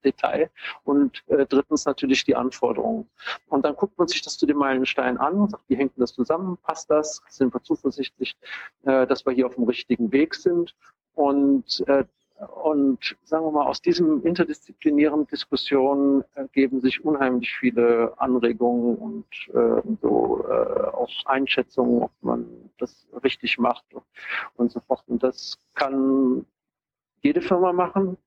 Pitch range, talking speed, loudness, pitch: 130-175 Hz, 160 wpm, -23 LUFS, 140 Hz